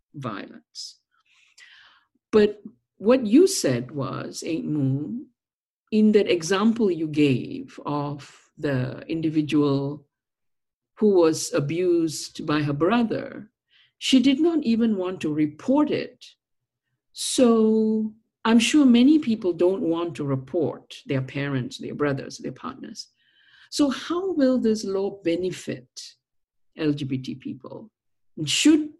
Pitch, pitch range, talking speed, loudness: 170 Hz, 145-230 Hz, 115 wpm, -23 LUFS